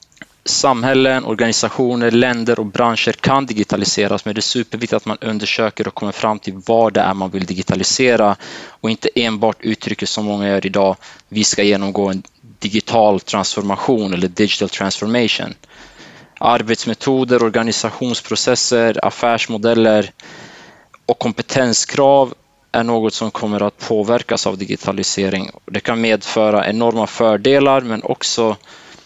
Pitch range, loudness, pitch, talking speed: 105-120 Hz, -16 LUFS, 110 Hz, 125 wpm